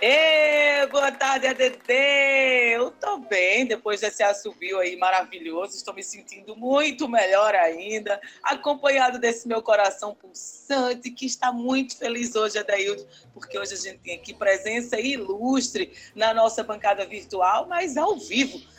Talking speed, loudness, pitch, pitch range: 140 wpm, -23 LUFS, 230 Hz, 200-270 Hz